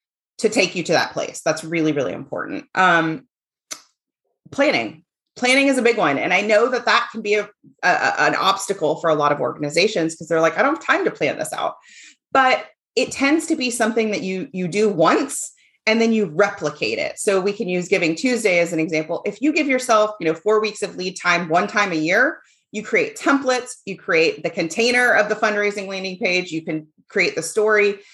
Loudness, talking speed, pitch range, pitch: -19 LUFS, 215 wpm, 170-235 Hz, 205 Hz